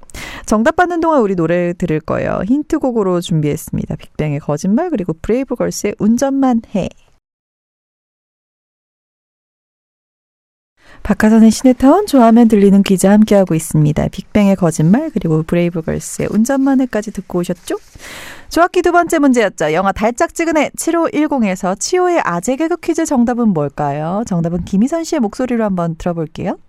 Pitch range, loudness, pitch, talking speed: 180-275 Hz, -14 LUFS, 215 Hz, 340 characters per minute